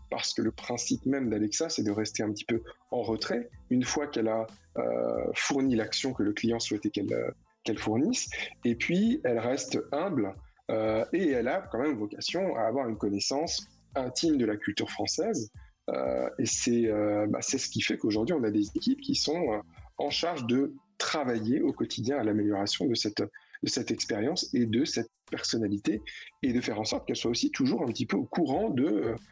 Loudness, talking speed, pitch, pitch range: -30 LUFS, 200 wpm, 115 Hz, 105-145 Hz